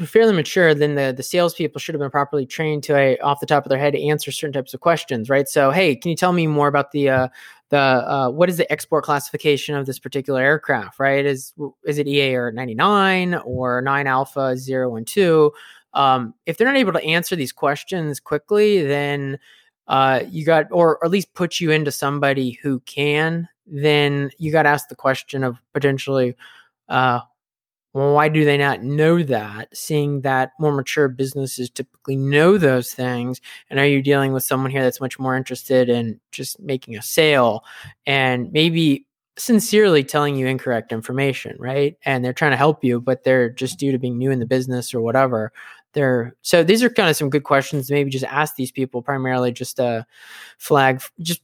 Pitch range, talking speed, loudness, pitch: 130-150 Hz, 200 wpm, -19 LUFS, 140 Hz